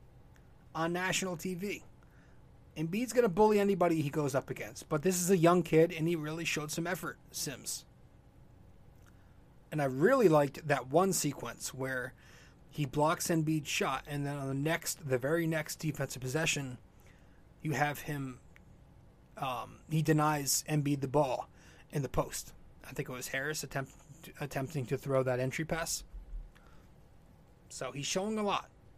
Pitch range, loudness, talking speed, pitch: 130-165 Hz, -33 LUFS, 155 wpm, 145 Hz